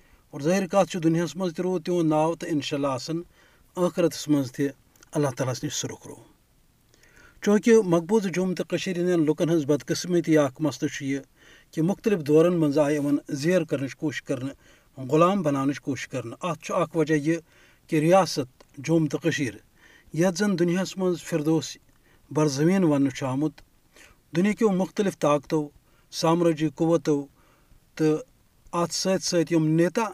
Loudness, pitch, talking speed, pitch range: -25 LUFS, 160 Hz, 130 wpm, 145-175 Hz